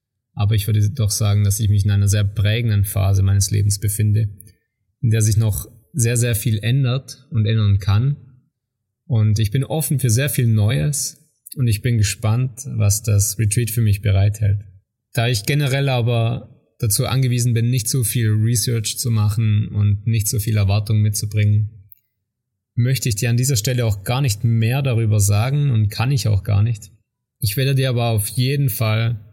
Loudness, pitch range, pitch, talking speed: -19 LUFS, 105-125 Hz, 115 Hz, 185 wpm